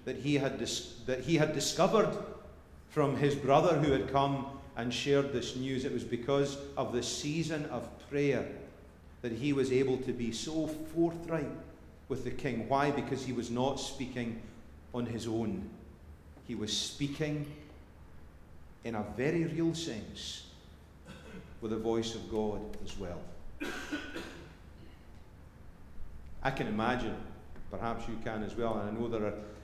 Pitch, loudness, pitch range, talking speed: 115 Hz, -34 LUFS, 95-140 Hz, 150 wpm